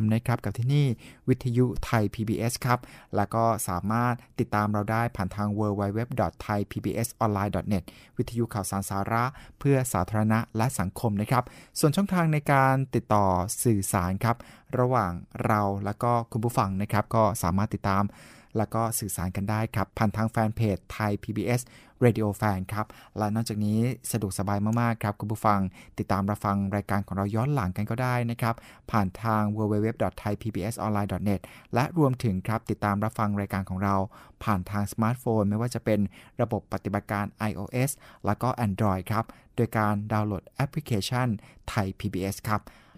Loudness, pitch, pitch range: -28 LUFS, 110 Hz, 100-115 Hz